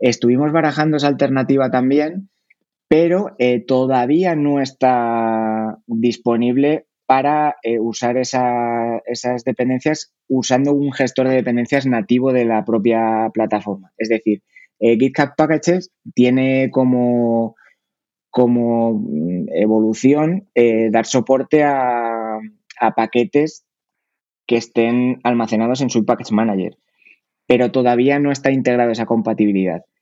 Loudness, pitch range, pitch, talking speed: -17 LUFS, 115-135 Hz, 125 Hz, 110 wpm